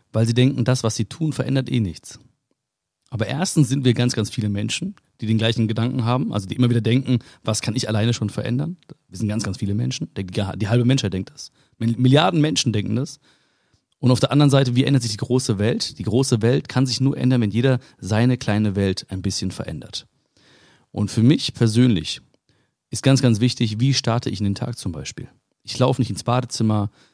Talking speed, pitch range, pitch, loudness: 210 wpm, 110-130 Hz, 120 Hz, -21 LUFS